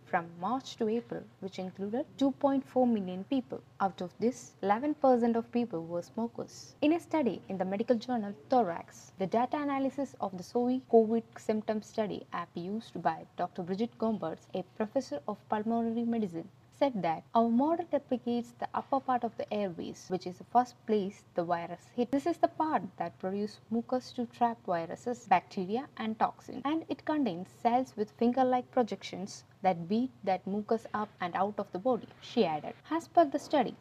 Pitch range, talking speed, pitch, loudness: 190-255 Hz, 180 wpm, 230 Hz, -33 LUFS